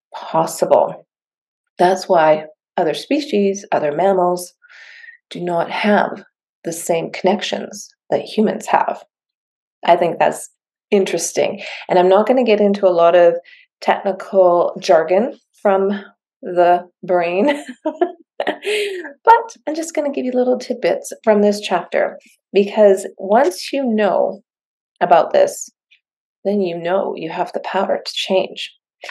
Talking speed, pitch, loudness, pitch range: 130 wpm, 200 Hz, -17 LUFS, 180-260 Hz